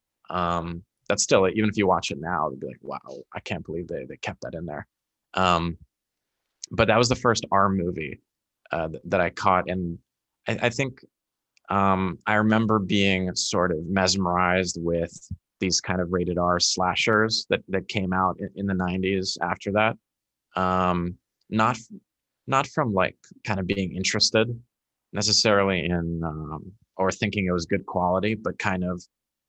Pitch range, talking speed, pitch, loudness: 90-105 Hz, 170 wpm, 95 Hz, -24 LUFS